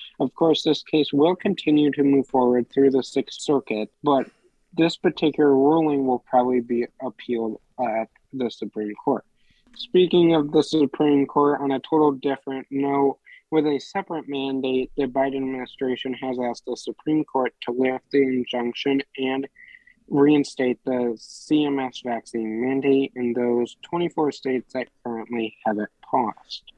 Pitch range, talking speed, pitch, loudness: 125-150 Hz, 150 wpm, 135 Hz, -23 LUFS